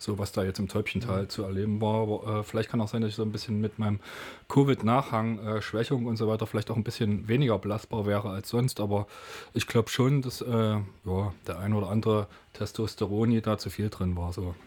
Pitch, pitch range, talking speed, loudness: 105 Hz, 100-115 Hz, 225 wpm, -29 LUFS